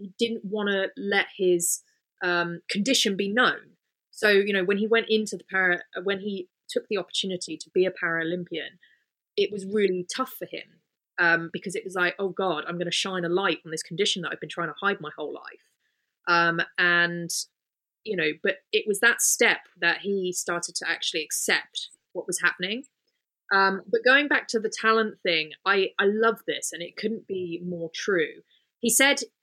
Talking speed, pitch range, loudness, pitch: 200 wpm, 175-220 Hz, -25 LUFS, 195 Hz